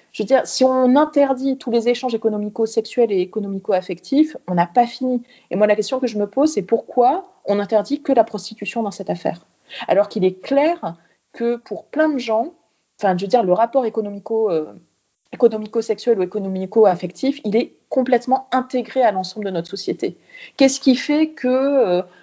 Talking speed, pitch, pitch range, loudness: 185 wpm, 230 Hz, 205-265 Hz, -19 LUFS